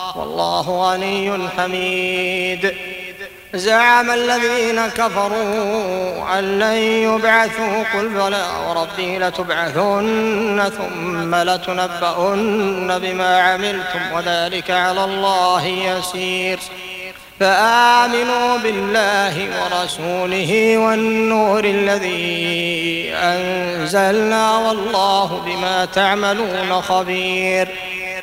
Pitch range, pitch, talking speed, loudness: 185-210 Hz, 185 Hz, 65 wpm, -17 LUFS